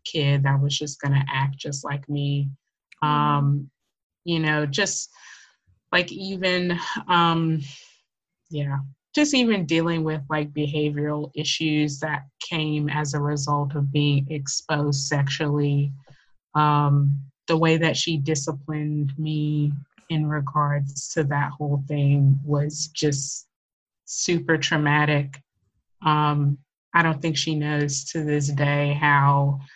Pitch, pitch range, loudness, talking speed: 150 Hz, 140-155 Hz, -23 LUFS, 120 wpm